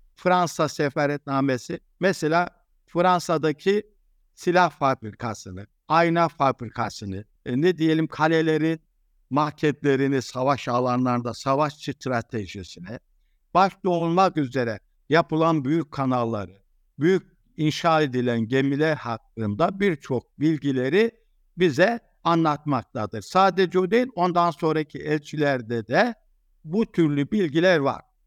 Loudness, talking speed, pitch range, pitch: -23 LUFS, 90 wpm, 130-175 Hz, 155 Hz